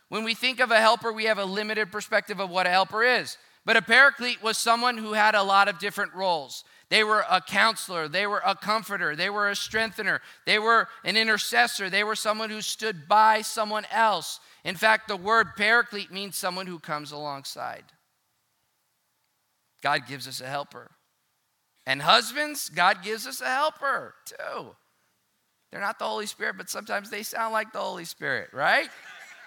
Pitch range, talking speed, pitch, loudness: 190-225 Hz, 180 wpm, 215 Hz, -24 LUFS